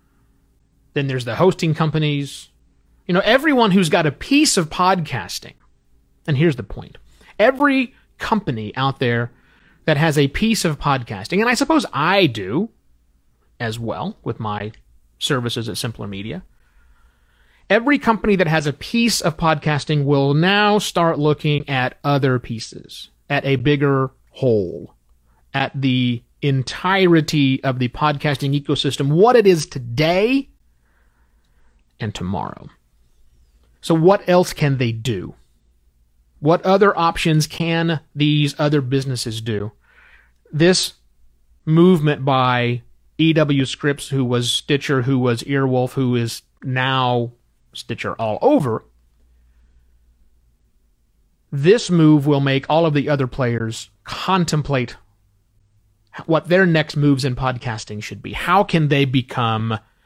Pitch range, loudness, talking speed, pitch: 105-160 Hz, -18 LUFS, 125 wpm, 135 Hz